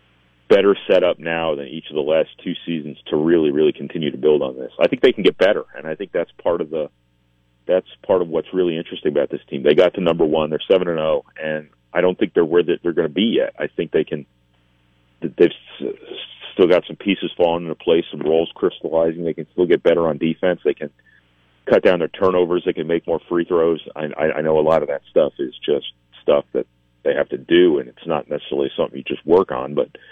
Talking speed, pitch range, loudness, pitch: 240 wpm, 60-90 Hz, -19 LUFS, 80 Hz